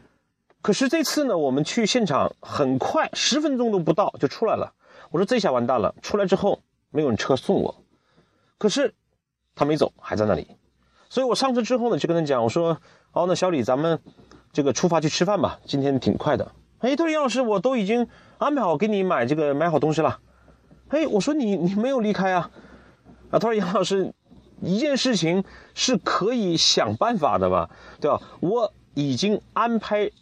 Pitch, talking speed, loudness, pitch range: 200 Hz, 280 characters per minute, -23 LUFS, 160-240 Hz